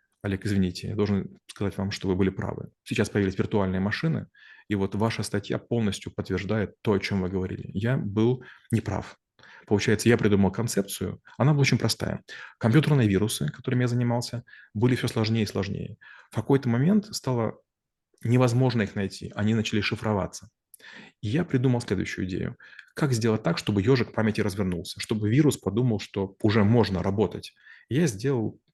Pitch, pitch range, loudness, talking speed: 110 Hz, 100-120 Hz, -26 LUFS, 160 wpm